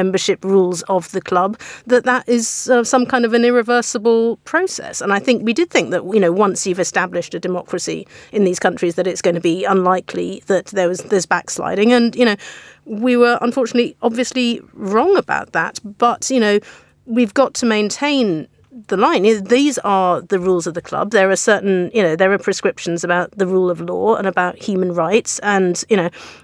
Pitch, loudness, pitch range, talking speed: 200 Hz, -16 LUFS, 180-240 Hz, 200 wpm